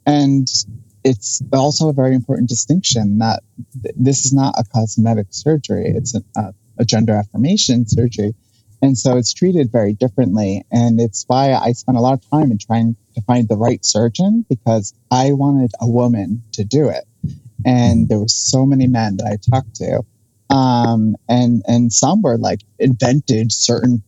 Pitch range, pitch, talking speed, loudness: 110-130 Hz, 120 Hz, 175 wpm, -15 LUFS